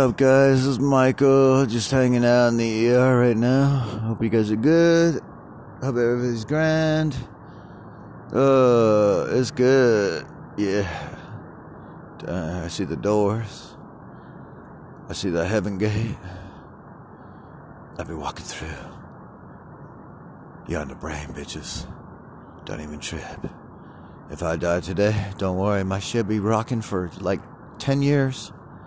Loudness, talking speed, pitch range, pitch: -21 LUFS, 130 wpm, 100-130 Hz, 115 Hz